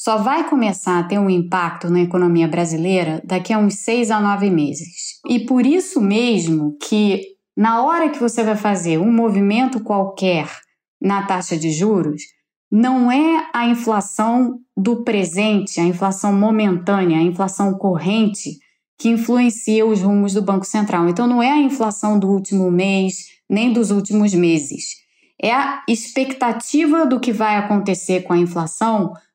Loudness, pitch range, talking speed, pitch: -17 LUFS, 185-230 Hz, 155 wpm, 205 Hz